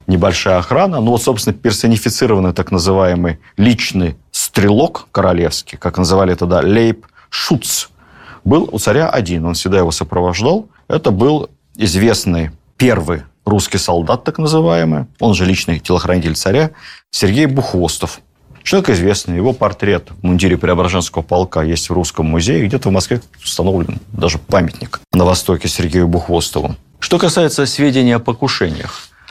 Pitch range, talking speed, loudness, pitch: 85-115 Hz, 135 wpm, -14 LUFS, 95 Hz